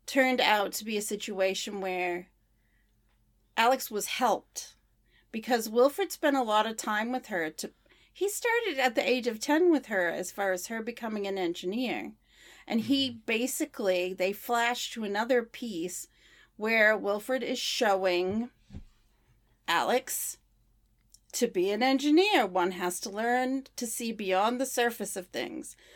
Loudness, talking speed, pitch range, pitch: -29 LUFS, 150 wpm, 185-250 Hz, 215 Hz